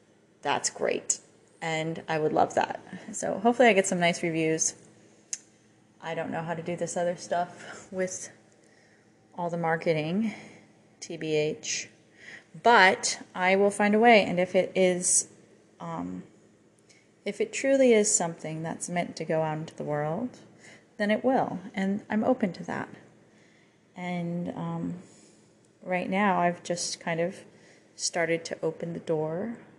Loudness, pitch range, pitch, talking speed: -27 LUFS, 160-200 Hz, 175 Hz, 145 wpm